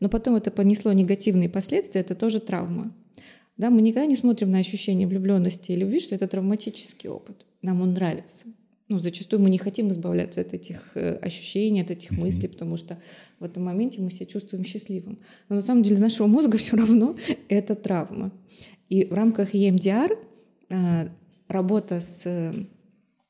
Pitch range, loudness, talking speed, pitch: 185-220 Hz, -24 LUFS, 165 wpm, 200 Hz